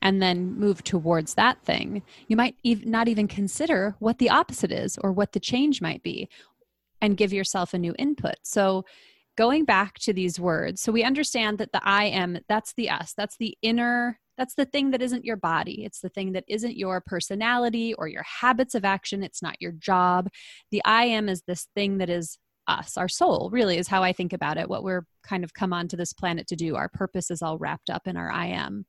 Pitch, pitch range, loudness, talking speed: 200 Hz, 180-230 Hz, -25 LUFS, 220 wpm